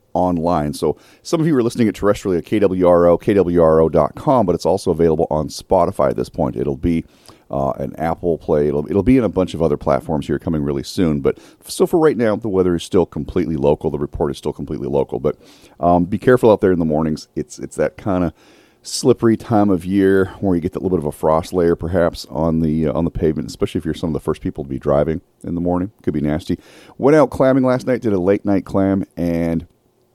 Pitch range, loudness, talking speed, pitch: 80-100 Hz, -18 LUFS, 240 wpm, 85 Hz